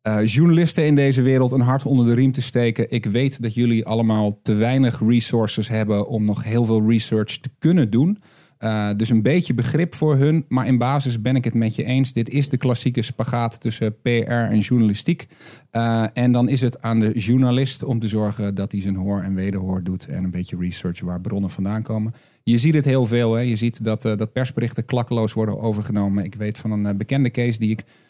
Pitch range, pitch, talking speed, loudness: 110-130 Hz, 115 Hz, 220 wpm, -20 LUFS